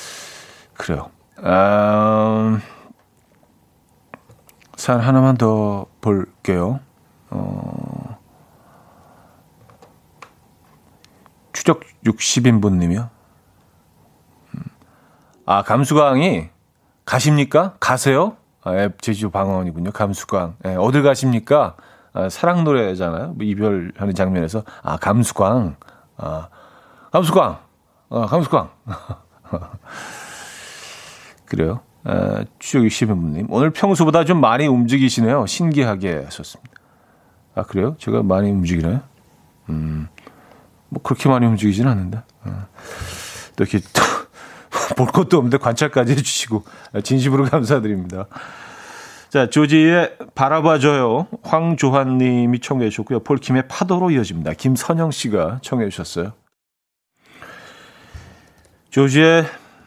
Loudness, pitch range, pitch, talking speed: -18 LUFS, 95-140 Hz, 115 Hz, 220 characters per minute